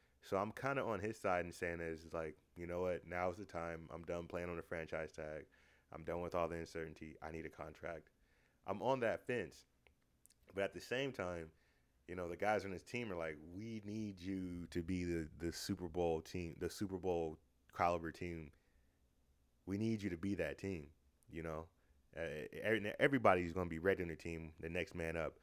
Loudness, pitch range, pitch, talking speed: -43 LUFS, 80-95 Hz, 85 Hz, 210 wpm